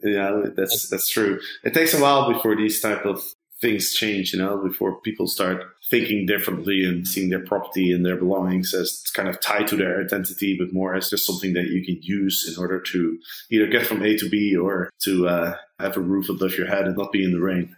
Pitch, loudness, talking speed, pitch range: 95 Hz, -22 LUFS, 235 wpm, 90-100 Hz